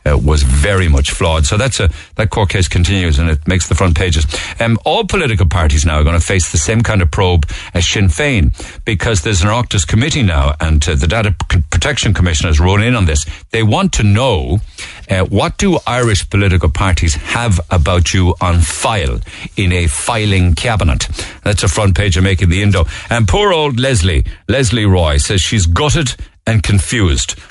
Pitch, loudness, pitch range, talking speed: 95 Hz, -13 LUFS, 85-105 Hz, 200 wpm